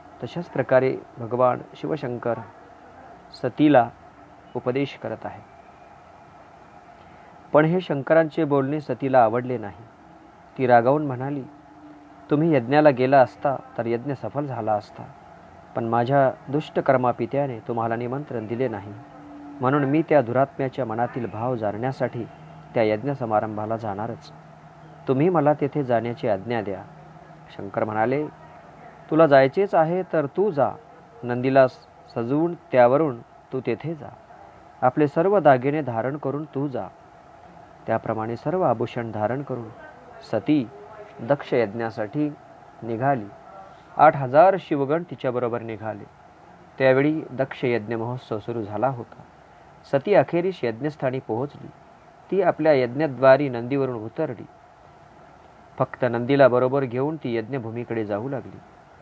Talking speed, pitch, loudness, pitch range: 110 wpm, 130 Hz, -23 LUFS, 115-145 Hz